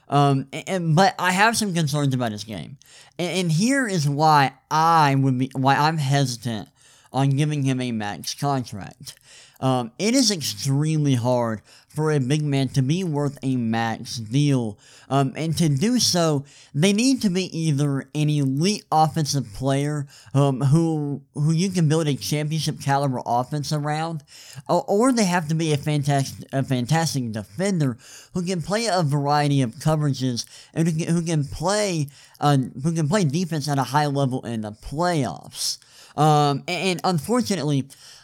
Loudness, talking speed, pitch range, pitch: -22 LUFS, 170 wpm, 135-165 Hz, 145 Hz